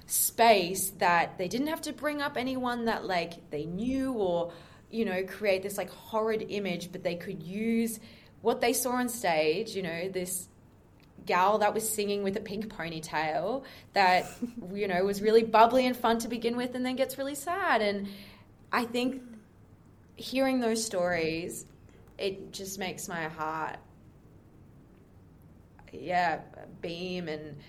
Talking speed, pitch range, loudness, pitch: 155 wpm, 180-235 Hz, -30 LUFS, 205 Hz